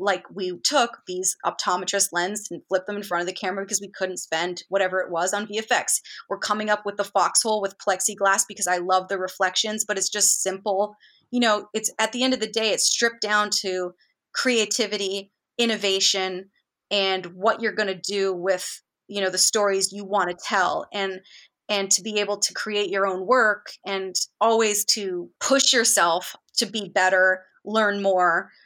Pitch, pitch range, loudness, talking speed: 200 Hz, 185-210 Hz, -23 LUFS, 190 wpm